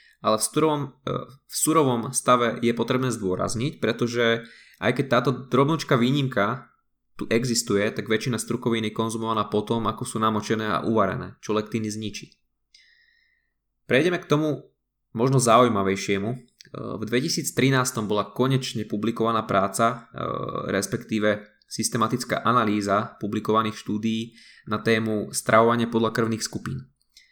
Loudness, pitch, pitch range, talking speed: -24 LUFS, 115 Hz, 110-125 Hz, 120 wpm